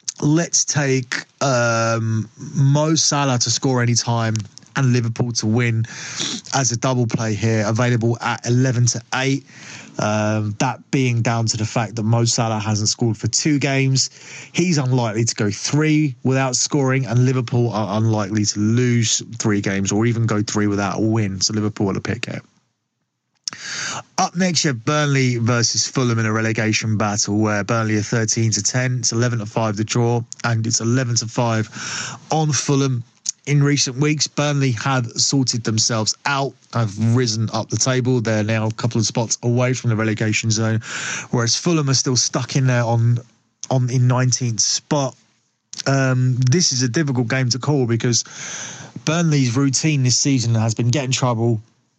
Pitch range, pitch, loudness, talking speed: 110-135 Hz, 120 Hz, -19 LUFS, 170 wpm